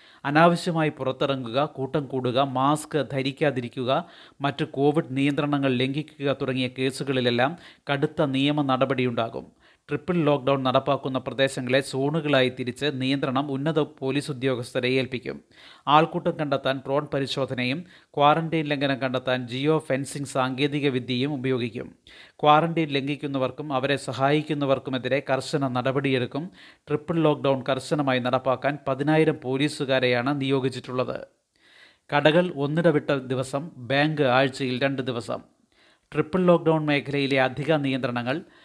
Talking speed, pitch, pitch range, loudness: 100 wpm, 140 Hz, 130-150 Hz, -24 LUFS